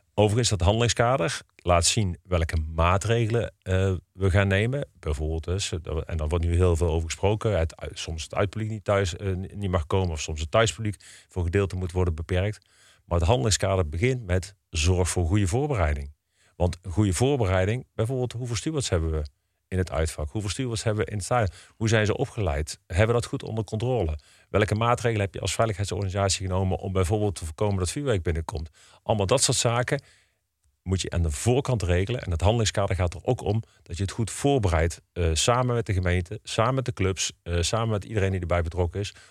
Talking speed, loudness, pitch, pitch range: 195 wpm, -26 LUFS, 95 Hz, 90-110 Hz